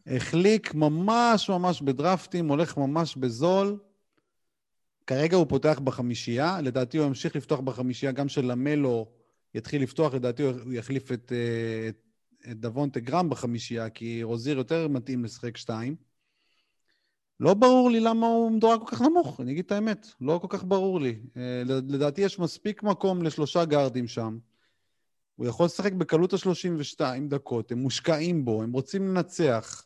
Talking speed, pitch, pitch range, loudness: 145 wpm, 145 Hz, 125-180 Hz, -27 LUFS